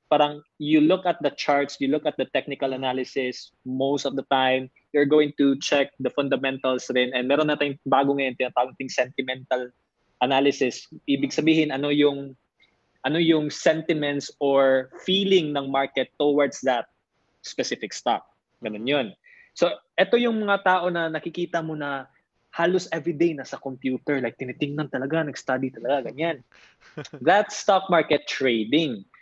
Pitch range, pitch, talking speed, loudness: 130-160 Hz, 140 Hz, 150 wpm, -24 LUFS